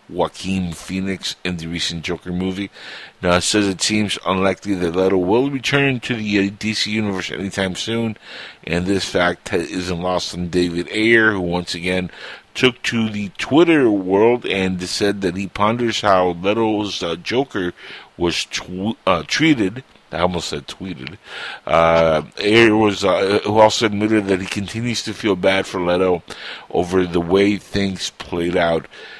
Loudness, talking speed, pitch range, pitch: -18 LUFS, 160 wpm, 90-105 Hz, 95 Hz